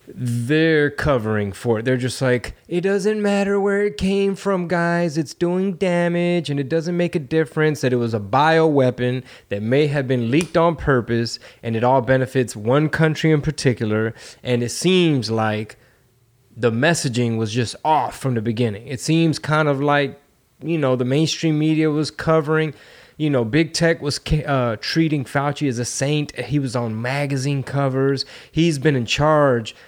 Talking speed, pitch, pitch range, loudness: 175 wpm, 145 Hz, 125-160 Hz, -20 LUFS